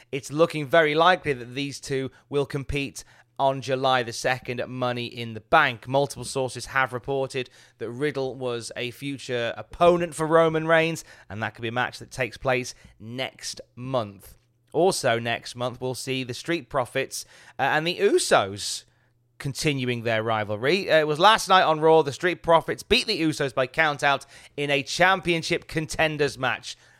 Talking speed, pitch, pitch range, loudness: 165 wpm, 135 Hz, 120-155 Hz, -24 LUFS